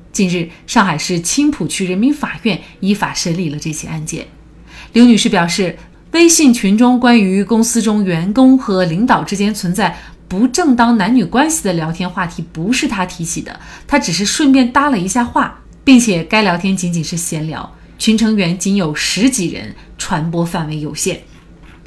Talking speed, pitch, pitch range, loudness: 265 characters per minute, 200 Hz, 175-240 Hz, -14 LUFS